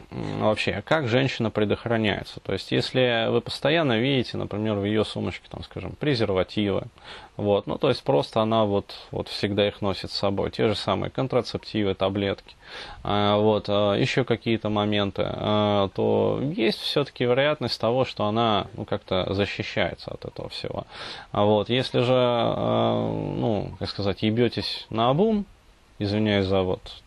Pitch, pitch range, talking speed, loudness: 105 Hz, 100-120 Hz, 140 wpm, -24 LUFS